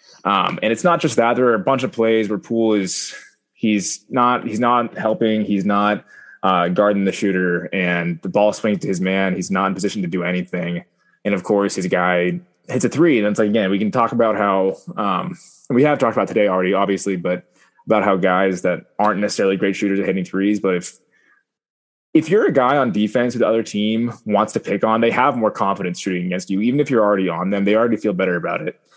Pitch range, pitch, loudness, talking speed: 90-110 Hz, 100 Hz, -18 LUFS, 230 wpm